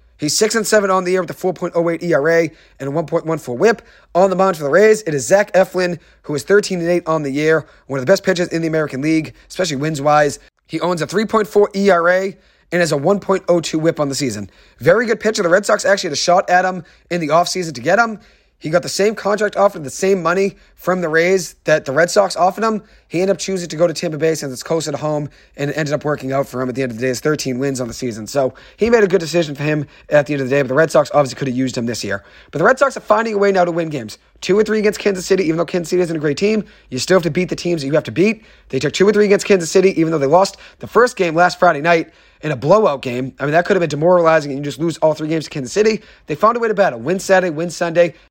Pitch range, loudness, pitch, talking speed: 150-190 Hz, -16 LUFS, 170 Hz, 300 wpm